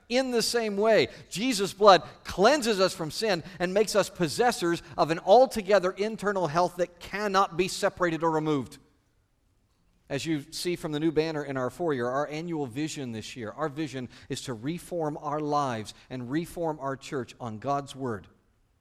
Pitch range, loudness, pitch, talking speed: 135-185 Hz, -27 LUFS, 160 Hz, 170 wpm